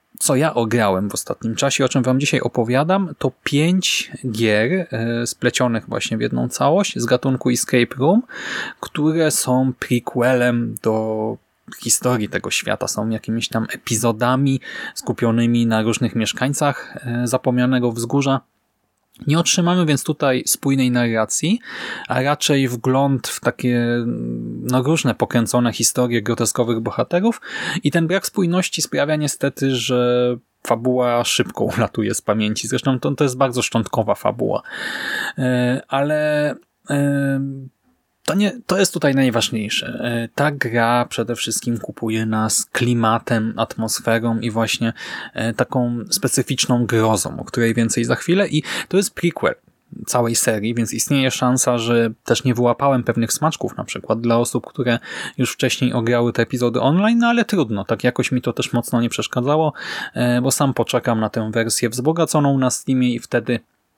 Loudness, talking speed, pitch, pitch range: -19 LUFS, 140 wpm, 125 Hz, 115-135 Hz